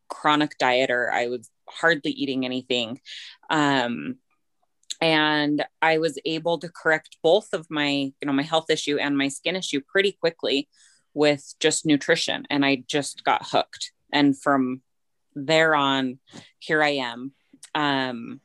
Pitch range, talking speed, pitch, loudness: 135-160 Hz, 145 wpm, 145 Hz, -23 LUFS